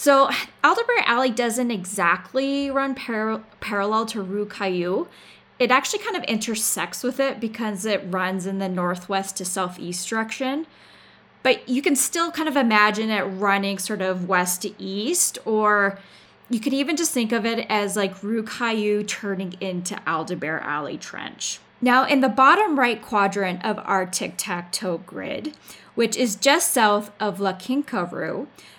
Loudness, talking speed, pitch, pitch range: -22 LUFS, 160 wpm, 215 Hz, 195-255 Hz